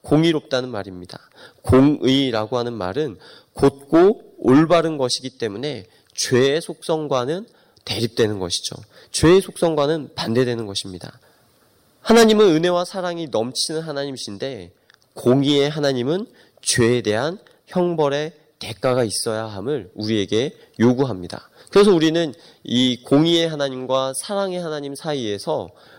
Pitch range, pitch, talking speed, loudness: 115-160 Hz, 140 Hz, 300 characters per minute, -20 LUFS